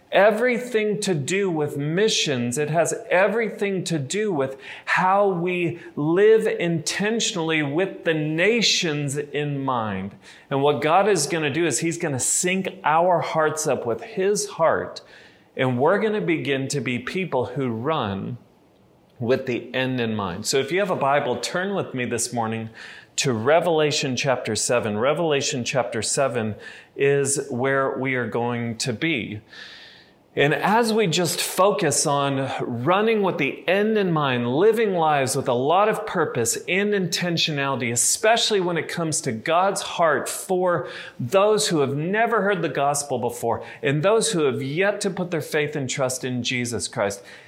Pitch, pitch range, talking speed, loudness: 155 Hz, 130-190 Hz, 165 wpm, -22 LUFS